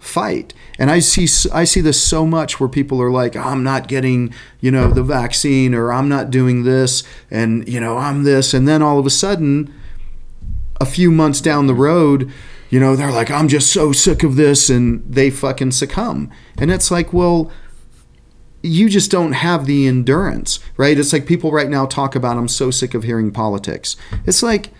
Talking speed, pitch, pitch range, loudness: 200 wpm, 135 Hz, 125-155 Hz, -14 LUFS